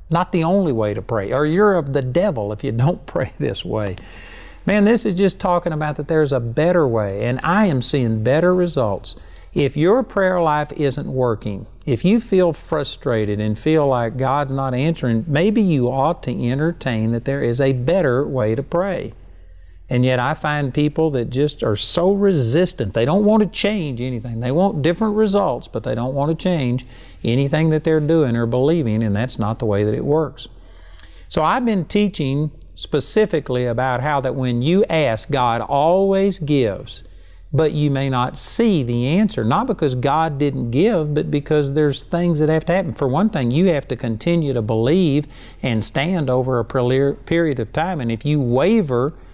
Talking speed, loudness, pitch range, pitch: 190 wpm, -19 LUFS, 120-170 Hz, 140 Hz